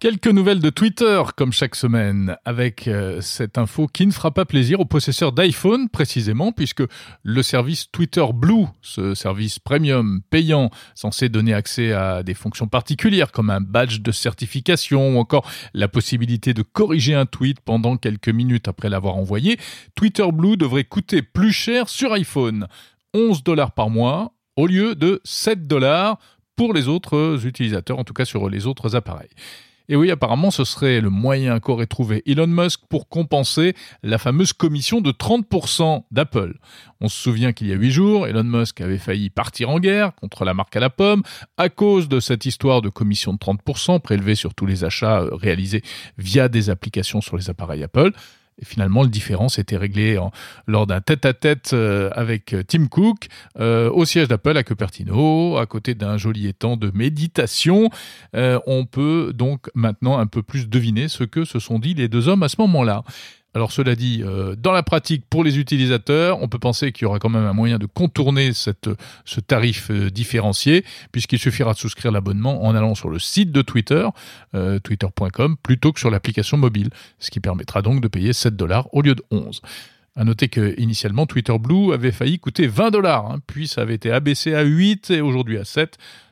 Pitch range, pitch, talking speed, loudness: 110-155 Hz, 125 Hz, 185 wpm, -19 LUFS